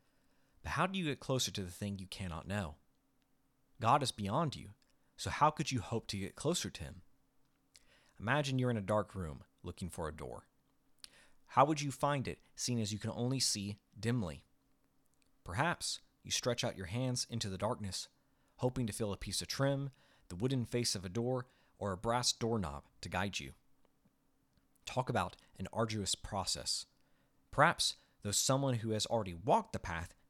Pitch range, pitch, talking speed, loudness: 95-130 Hz, 110 Hz, 180 wpm, -37 LUFS